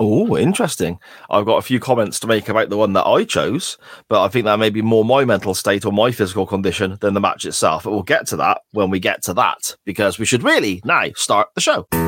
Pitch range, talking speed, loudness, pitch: 105-115 Hz, 255 wpm, -17 LUFS, 110 Hz